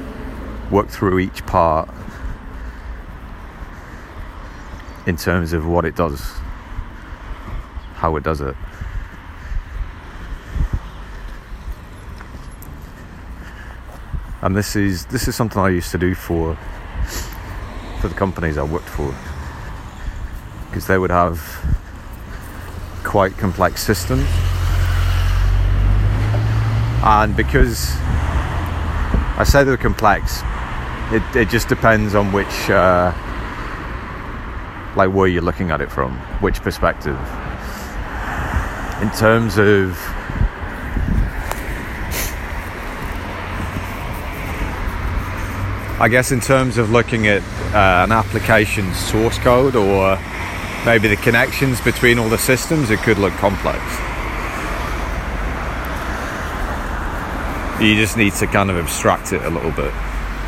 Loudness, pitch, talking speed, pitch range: -18 LUFS, 90 Hz, 95 wpm, 80-100 Hz